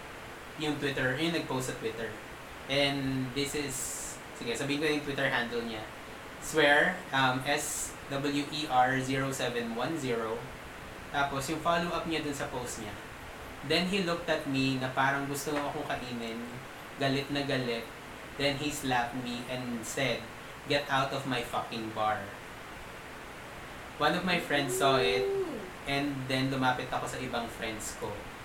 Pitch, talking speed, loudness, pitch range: 135 Hz, 140 wpm, -31 LUFS, 125-145 Hz